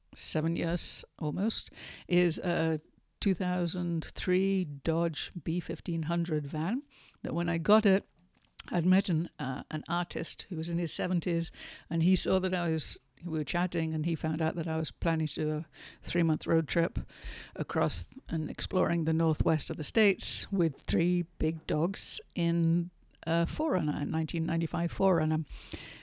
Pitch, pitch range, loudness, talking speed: 165 Hz, 160-175 Hz, -30 LUFS, 155 wpm